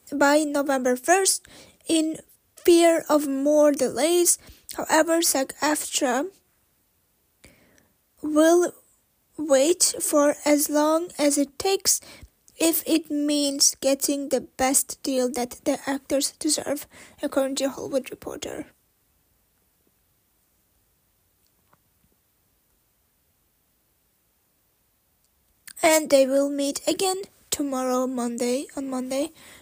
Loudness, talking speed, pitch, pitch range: -22 LUFS, 85 wpm, 290 Hz, 270-315 Hz